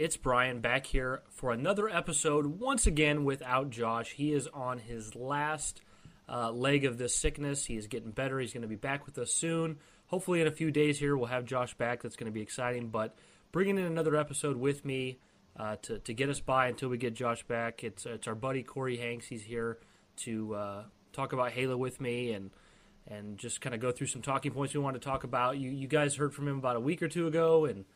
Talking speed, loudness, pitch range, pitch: 235 wpm, -33 LUFS, 120-145 Hz, 130 Hz